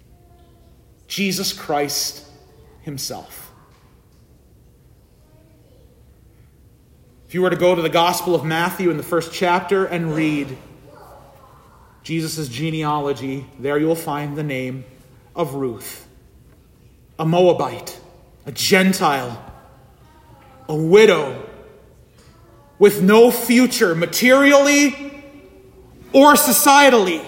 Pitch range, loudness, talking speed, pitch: 140-190 Hz, -16 LUFS, 90 wpm, 165 Hz